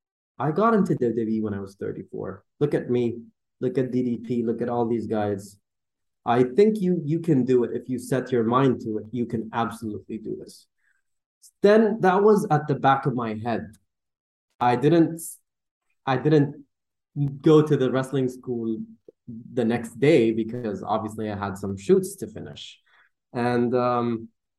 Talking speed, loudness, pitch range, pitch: 170 wpm, -24 LUFS, 110-145 Hz, 120 Hz